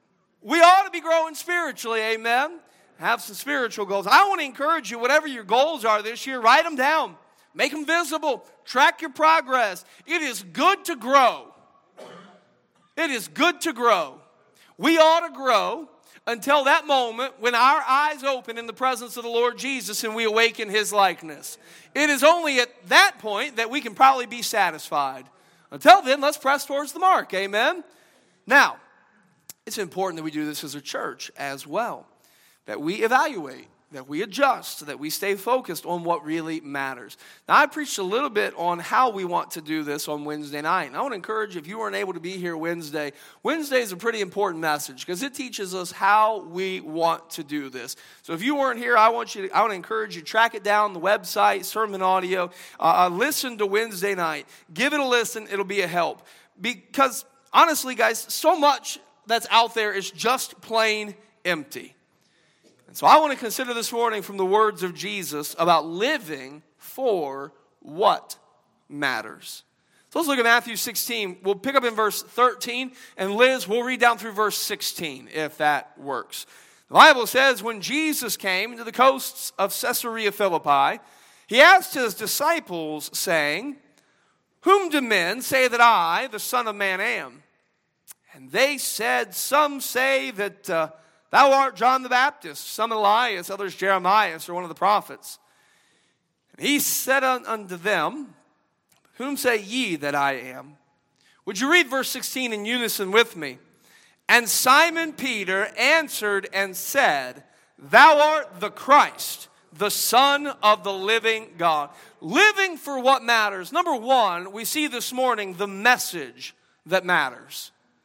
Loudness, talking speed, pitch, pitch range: -22 LUFS, 175 wpm, 225 Hz, 190-270 Hz